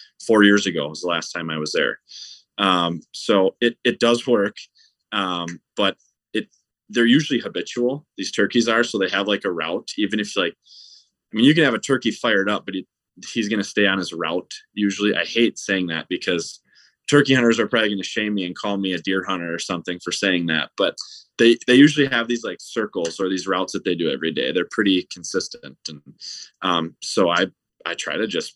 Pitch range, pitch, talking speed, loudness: 90-115 Hz, 100 Hz, 220 wpm, -21 LUFS